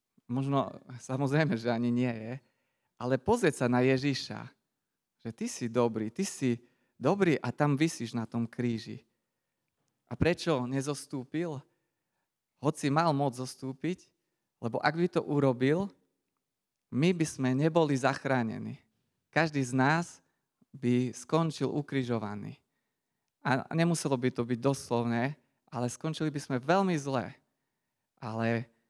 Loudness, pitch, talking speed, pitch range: -31 LUFS, 135 Hz, 125 wpm, 120-155 Hz